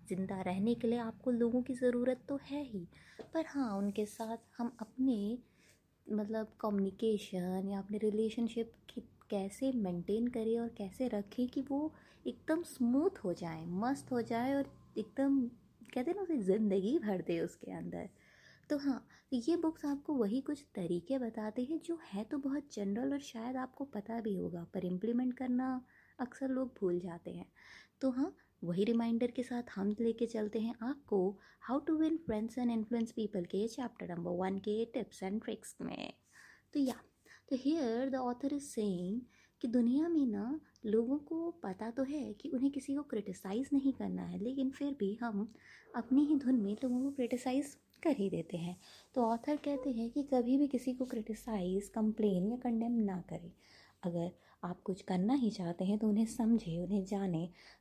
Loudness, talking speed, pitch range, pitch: -37 LUFS, 180 wpm, 205-265 Hz, 235 Hz